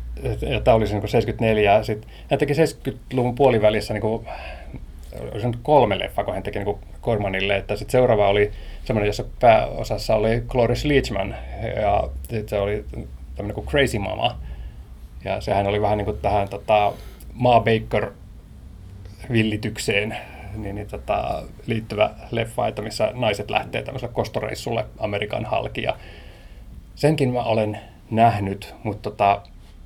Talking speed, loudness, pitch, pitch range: 135 wpm, -22 LUFS, 105 Hz, 95-110 Hz